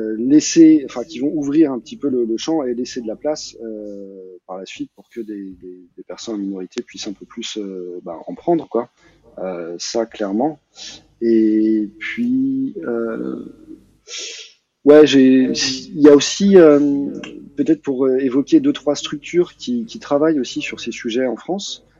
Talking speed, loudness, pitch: 175 wpm, -17 LUFS, 135 Hz